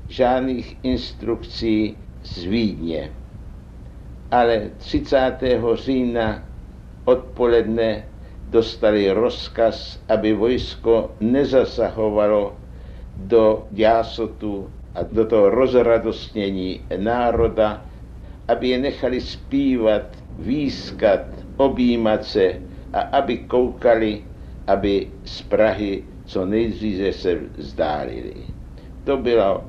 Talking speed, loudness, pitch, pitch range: 80 wpm, -20 LUFS, 110 Hz, 95-115 Hz